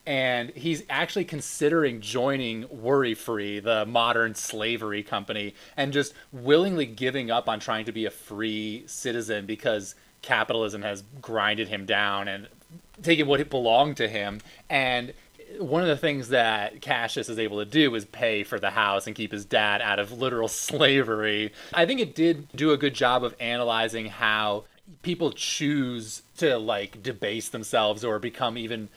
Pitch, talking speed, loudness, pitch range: 115 Hz, 165 wpm, -26 LUFS, 110-140 Hz